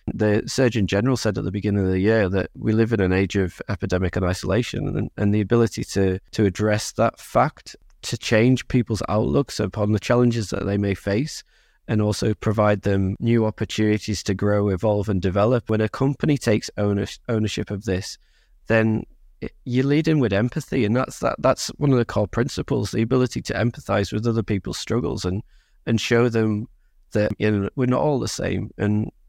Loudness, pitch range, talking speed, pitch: -22 LUFS, 100-120 Hz, 195 wpm, 105 Hz